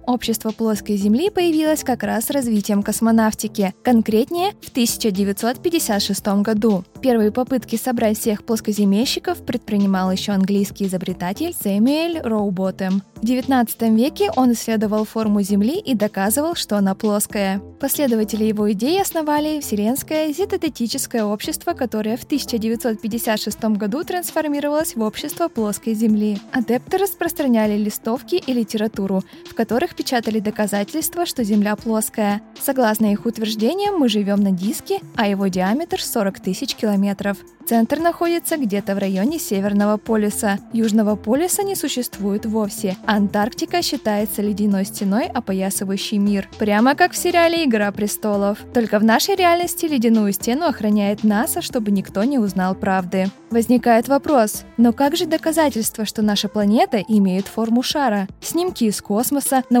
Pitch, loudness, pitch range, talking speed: 225 Hz, -19 LUFS, 210-275 Hz, 130 wpm